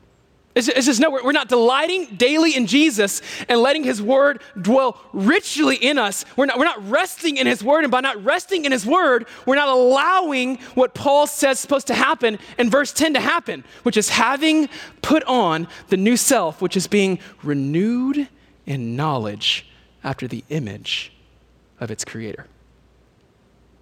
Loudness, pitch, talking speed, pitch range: -18 LUFS, 255 Hz, 170 wpm, 190-285 Hz